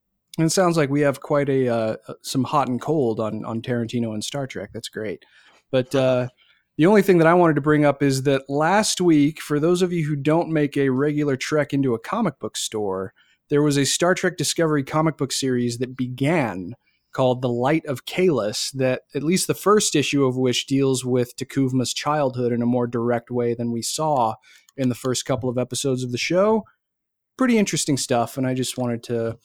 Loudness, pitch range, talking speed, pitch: -21 LUFS, 125-155 Hz, 210 wpm, 135 Hz